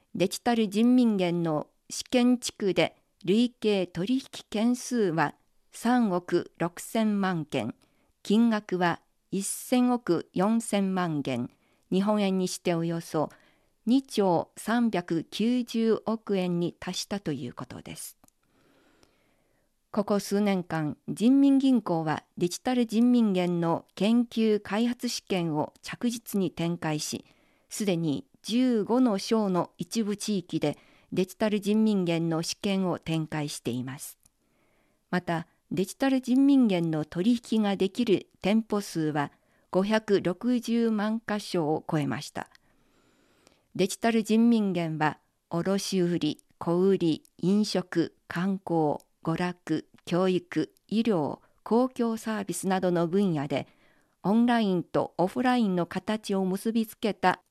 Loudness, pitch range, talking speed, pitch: -28 LUFS, 170-225 Hz, 215 characters per minute, 195 Hz